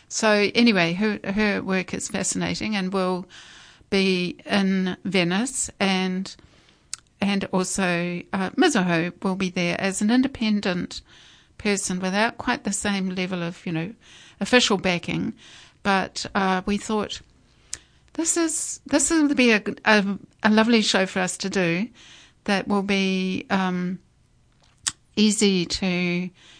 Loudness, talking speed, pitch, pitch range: -23 LUFS, 130 wpm, 195 Hz, 185-215 Hz